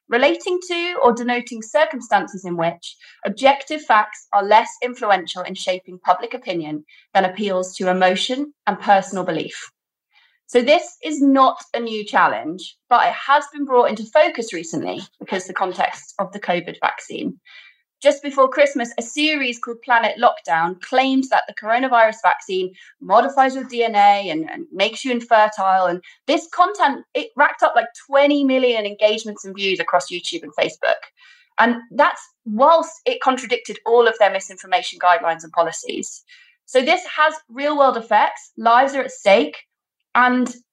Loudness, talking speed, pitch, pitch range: -18 LUFS, 155 wpm, 240 Hz, 195-285 Hz